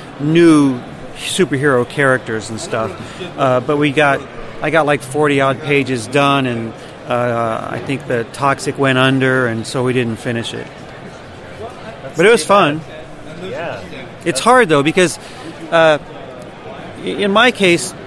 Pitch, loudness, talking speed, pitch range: 140 Hz, -15 LUFS, 140 wpm, 125-160 Hz